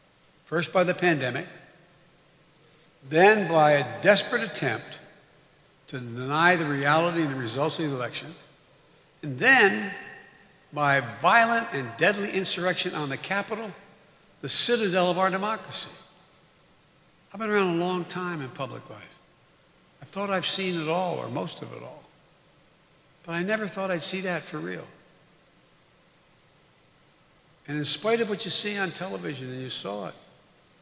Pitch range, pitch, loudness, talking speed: 150-190 Hz, 175 Hz, -25 LUFS, 150 wpm